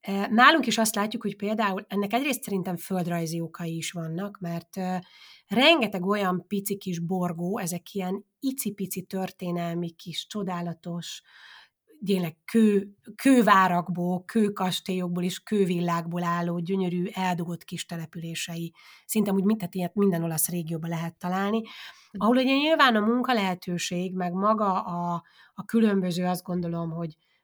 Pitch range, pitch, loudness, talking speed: 175-205 Hz, 185 Hz, -26 LUFS, 125 wpm